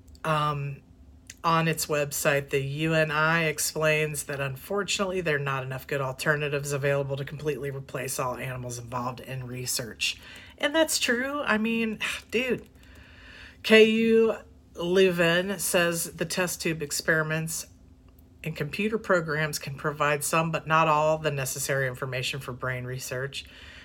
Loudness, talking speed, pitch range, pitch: -26 LUFS, 130 wpm, 130-165 Hz, 145 Hz